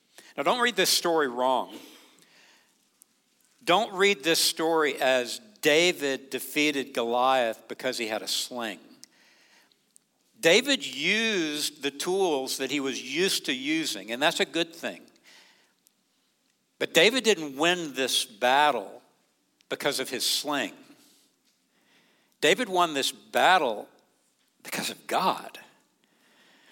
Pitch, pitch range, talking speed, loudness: 165 Hz, 135-220 Hz, 115 wpm, -25 LUFS